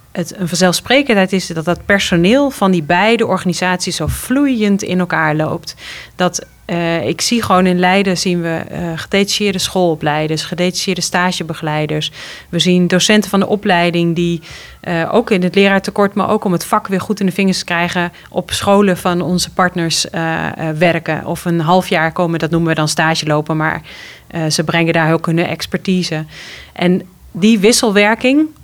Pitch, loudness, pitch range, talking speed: 180 Hz, -14 LUFS, 165-195 Hz, 170 wpm